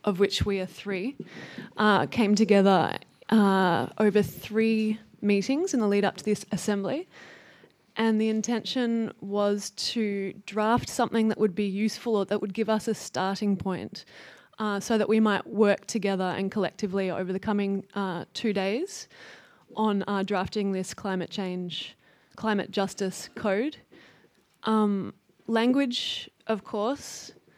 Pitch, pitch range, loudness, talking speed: 210 Hz, 195-220 Hz, -27 LUFS, 145 wpm